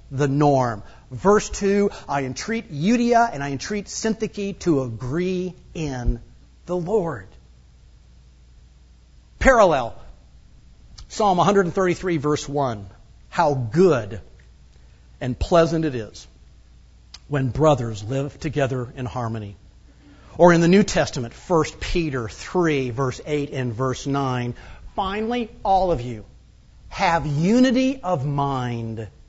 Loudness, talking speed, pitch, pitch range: -22 LUFS, 110 wpm, 135 Hz, 105-175 Hz